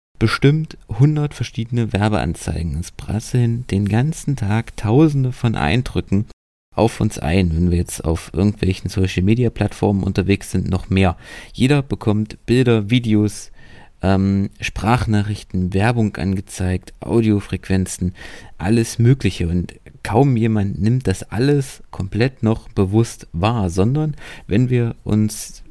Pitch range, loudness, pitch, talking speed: 95-120 Hz, -19 LUFS, 105 Hz, 120 wpm